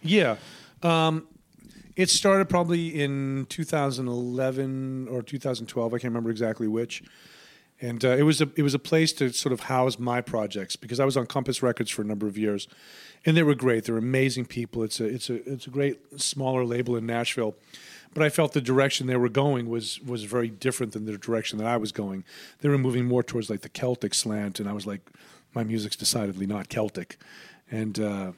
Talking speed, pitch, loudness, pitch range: 205 wpm, 125 Hz, -26 LUFS, 110-140 Hz